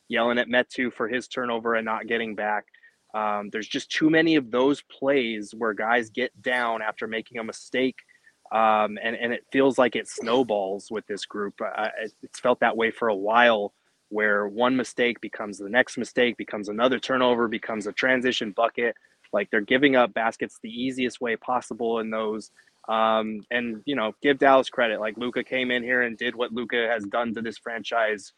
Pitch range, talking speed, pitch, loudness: 110-125 Hz, 195 wpm, 120 Hz, -25 LUFS